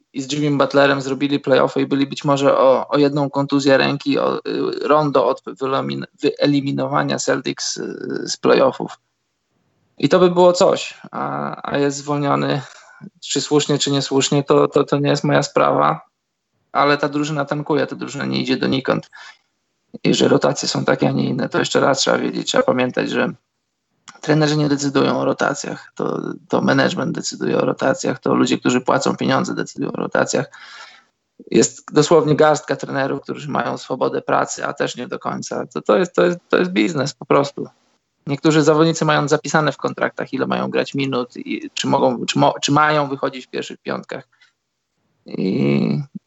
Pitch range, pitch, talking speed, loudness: 125-150 Hz, 140 Hz, 175 wpm, -18 LUFS